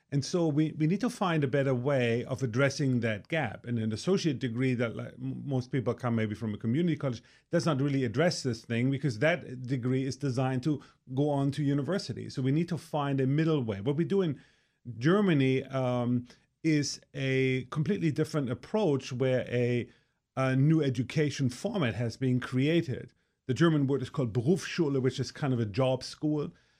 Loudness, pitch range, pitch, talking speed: -30 LUFS, 125-155 Hz, 135 Hz, 195 wpm